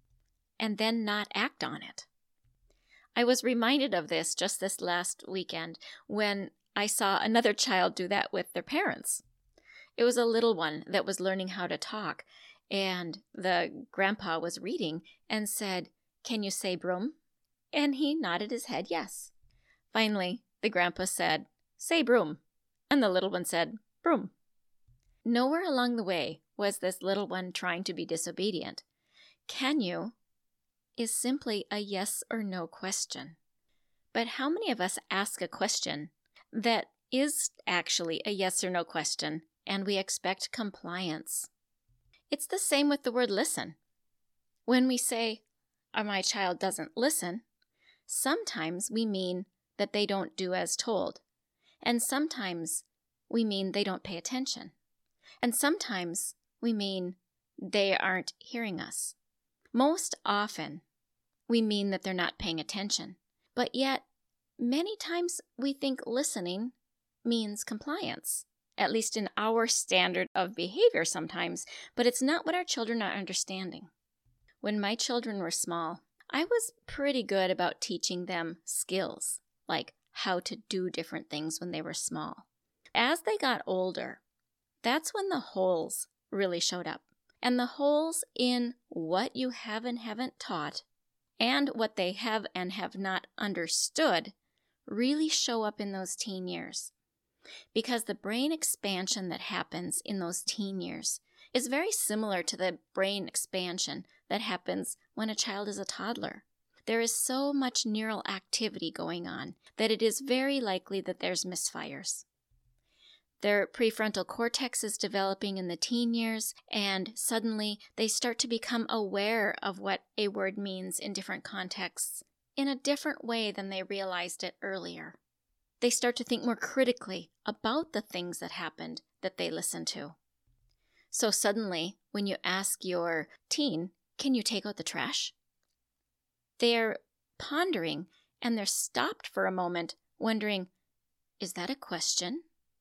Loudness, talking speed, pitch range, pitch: -32 LUFS, 150 wpm, 185-245 Hz, 205 Hz